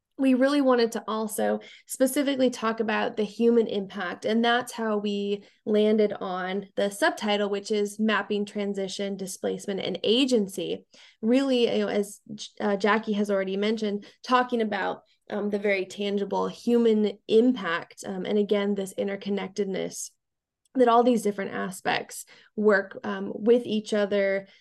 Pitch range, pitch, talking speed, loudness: 200-230 Hz, 210 Hz, 140 wpm, -26 LUFS